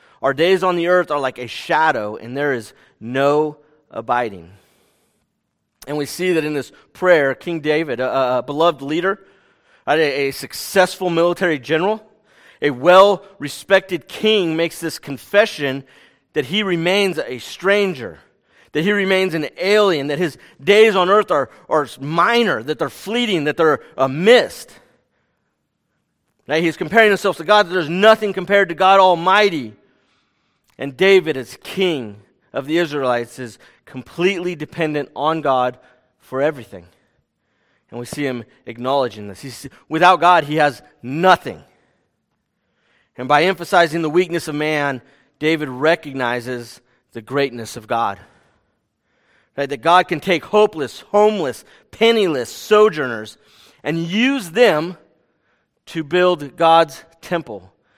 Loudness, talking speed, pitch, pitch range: -17 LUFS, 135 wpm, 160 Hz, 135-185 Hz